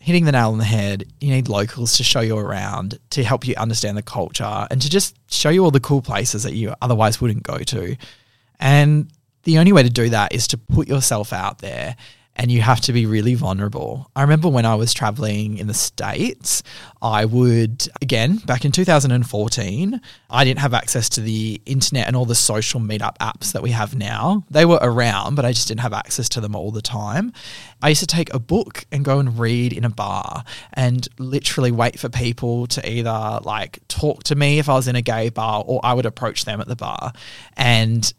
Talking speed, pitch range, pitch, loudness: 220 wpm, 110-135 Hz, 120 Hz, -19 LUFS